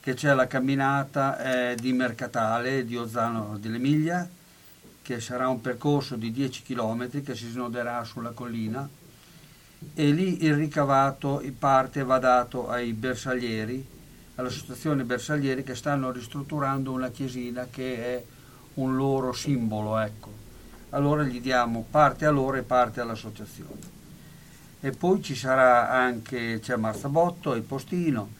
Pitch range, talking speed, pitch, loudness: 120-140 Hz, 135 wpm, 130 Hz, -27 LUFS